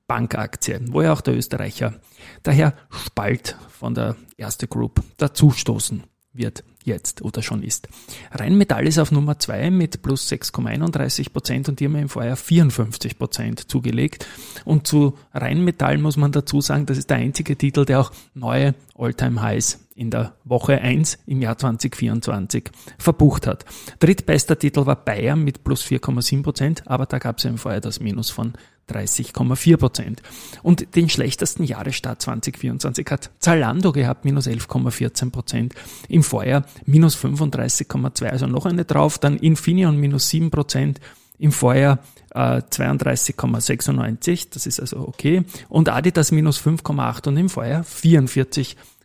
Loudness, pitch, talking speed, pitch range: -20 LUFS, 135 Hz, 145 wpm, 120-150 Hz